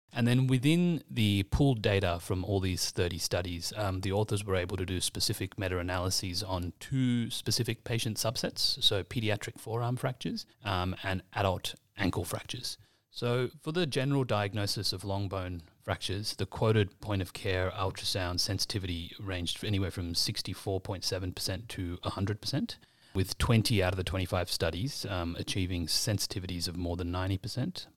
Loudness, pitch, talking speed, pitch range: -32 LUFS, 100 Hz, 155 wpm, 95-115 Hz